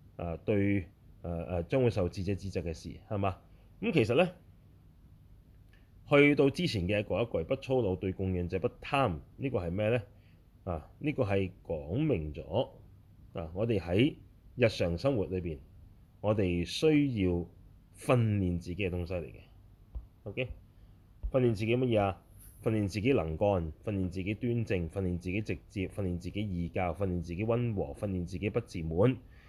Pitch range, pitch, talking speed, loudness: 90-105 Hz, 95 Hz, 250 characters per minute, -32 LUFS